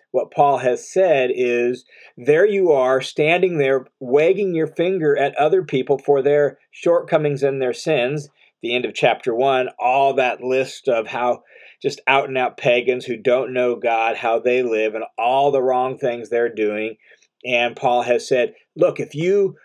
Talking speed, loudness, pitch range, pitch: 175 wpm, -19 LUFS, 120-145 Hz, 130 Hz